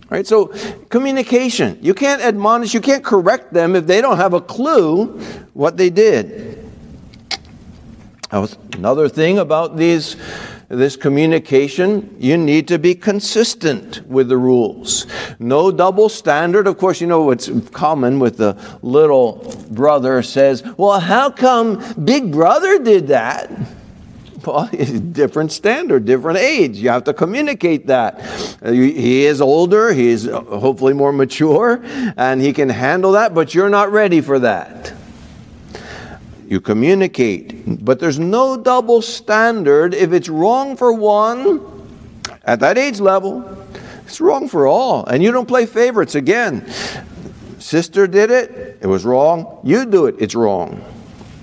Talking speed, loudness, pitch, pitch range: 140 wpm, -14 LUFS, 190 Hz, 145-235 Hz